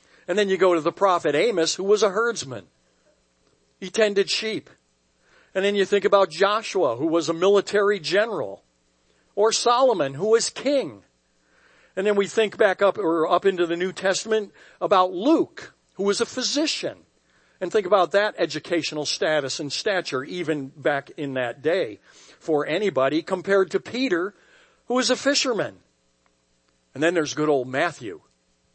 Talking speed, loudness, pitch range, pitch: 160 wpm, -22 LUFS, 145-210 Hz, 185 Hz